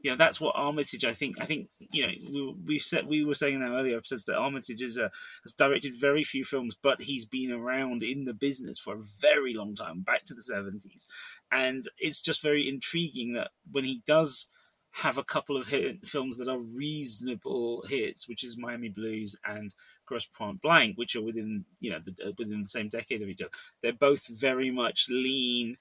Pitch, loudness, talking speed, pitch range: 130 Hz, -30 LUFS, 210 wpm, 115-140 Hz